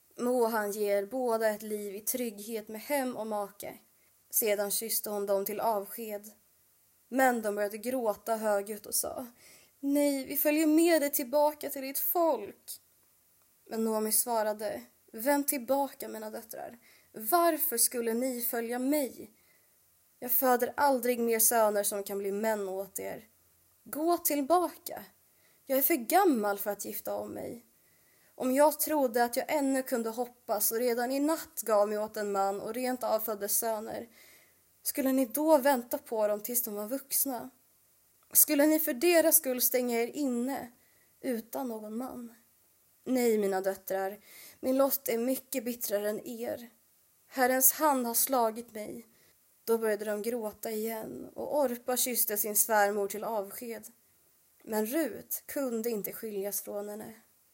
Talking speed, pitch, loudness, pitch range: 150 wpm, 235 Hz, -30 LUFS, 215-270 Hz